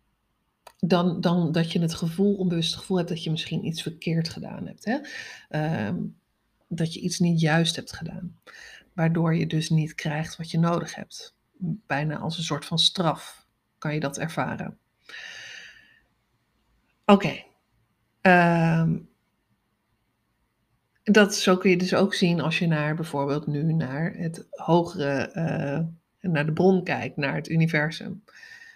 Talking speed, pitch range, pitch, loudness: 150 wpm, 155-185 Hz, 165 Hz, -25 LUFS